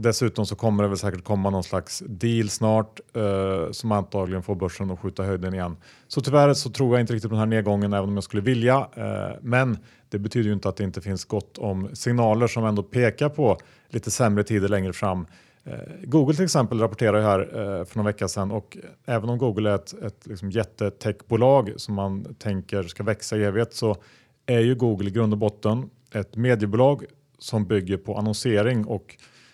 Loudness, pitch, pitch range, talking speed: -24 LUFS, 105 Hz, 100-120 Hz, 205 wpm